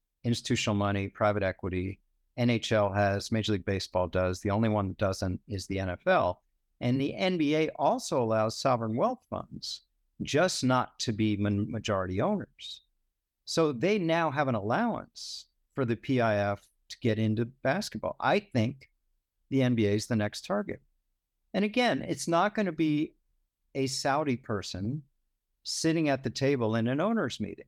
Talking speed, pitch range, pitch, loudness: 155 wpm, 100-140 Hz, 115 Hz, -29 LUFS